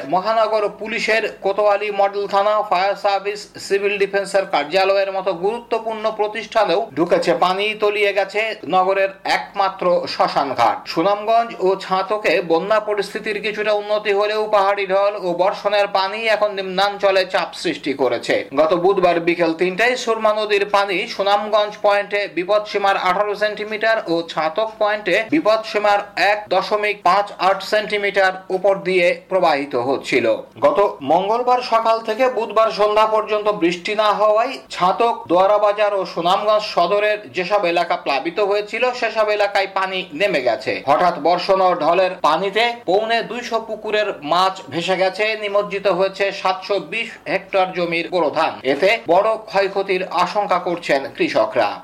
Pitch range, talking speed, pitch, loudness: 190-215 Hz, 130 wpm, 205 Hz, -18 LUFS